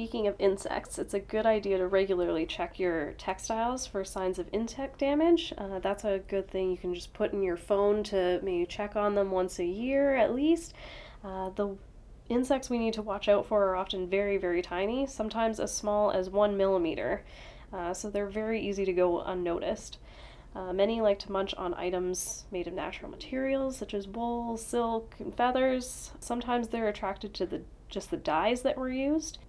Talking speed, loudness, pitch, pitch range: 195 wpm, -31 LUFS, 205 Hz, 190-235 Hz